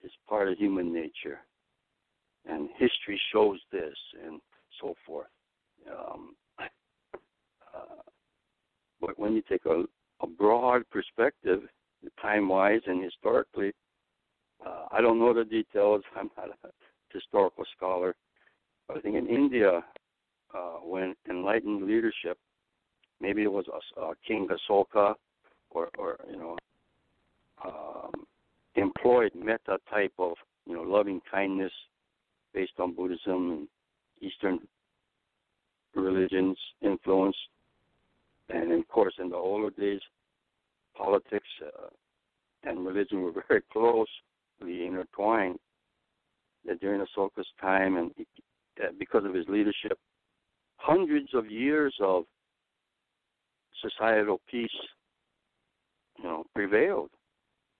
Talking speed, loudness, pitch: 110 wpm, -29 LUFS, 110 Hz